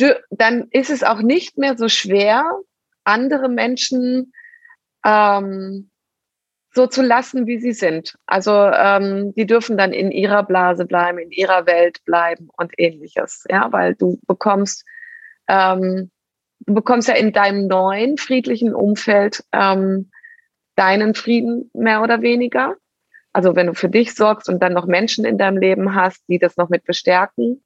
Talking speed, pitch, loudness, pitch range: 150 wpm, 205 Hz, -16 LUFS, 185-245 Hz